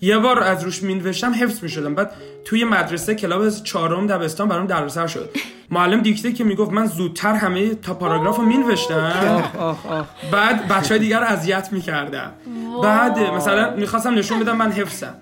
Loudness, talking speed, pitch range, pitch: -19 LUFS, 165 wpm, 175-220 Hz, 200 Hz